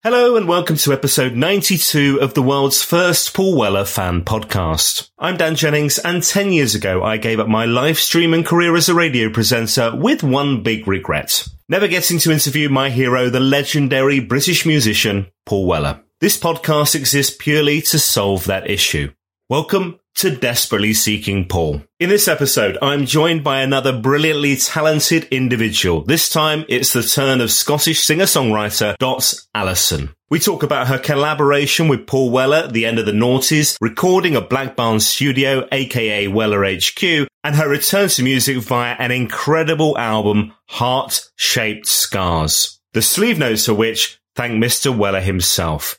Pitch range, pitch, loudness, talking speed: 110-155 Hz, 135 Hz, -15 LUFS, 165 wpm